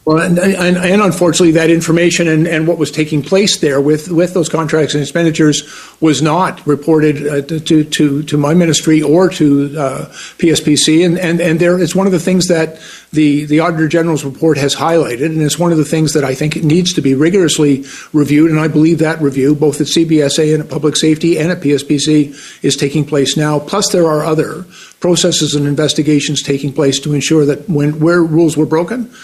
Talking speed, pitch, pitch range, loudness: 205 wpm, 155 Hz, 150-170 Hz, -12 LUFS